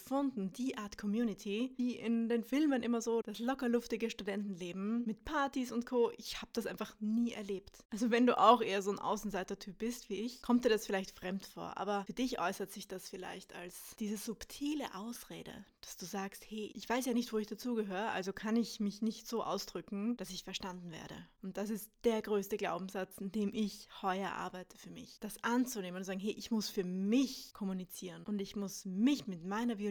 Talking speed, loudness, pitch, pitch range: 210 wpm, -37 LUFS, 215 Hz, 195-235 Hz